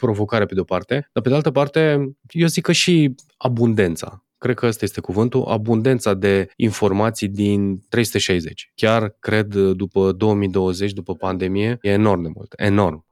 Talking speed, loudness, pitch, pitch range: 165 wpm, -19 LUFS, 105 Hz, 100-125 Hz